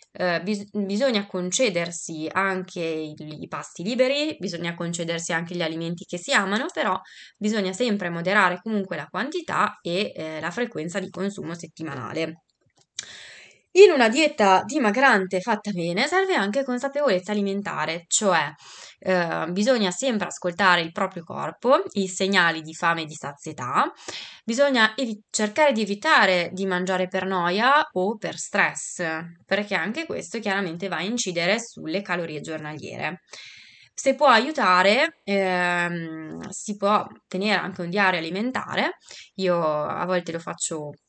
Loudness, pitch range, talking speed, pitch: -23 LUFS, 170-215 Hz, 135 wpm, 190 Hz